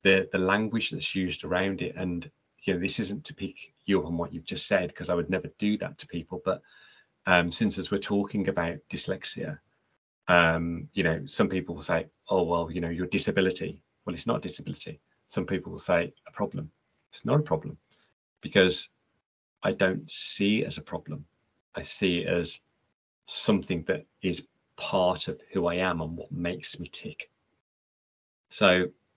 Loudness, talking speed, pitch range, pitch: -29 LUFS, 185 wpm, 85-95 Hz, 90 Hz